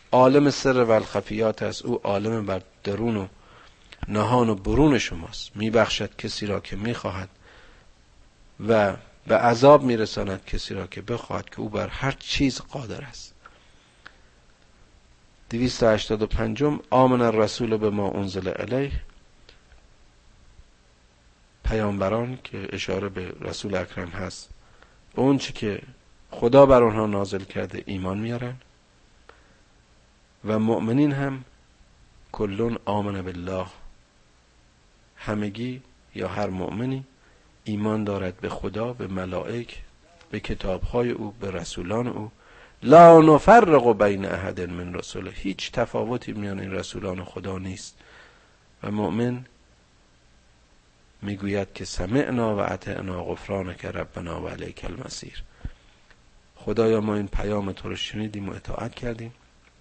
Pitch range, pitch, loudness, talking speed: 95-115 Hz, 105 Hz, -23 LUFS, 120 wpm